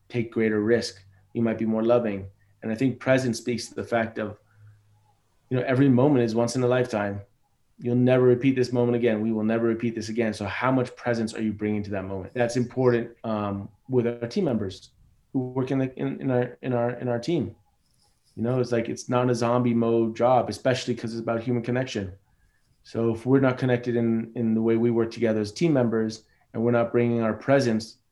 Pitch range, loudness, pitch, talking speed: 110-125 Hz, -25 LUFS, 115 Hz, 220 wpm